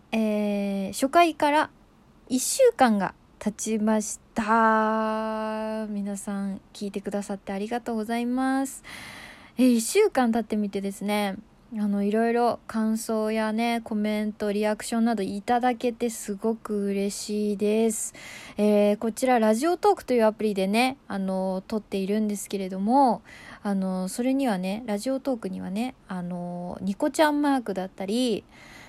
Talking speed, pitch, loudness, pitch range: 295 characters per minute, 220 Hz, -26 LUFS, 200-240 Hz